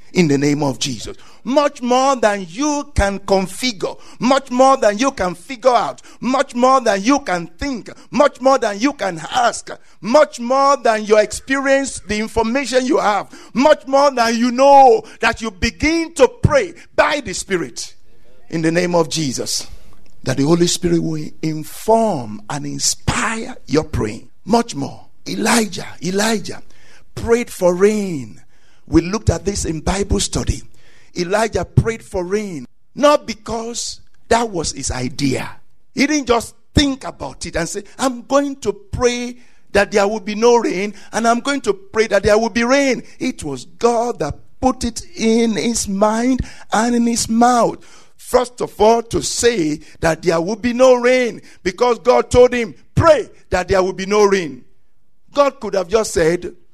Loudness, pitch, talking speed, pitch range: -17 LUFS, 225 Hz, 170 wpm, 180-255 Hz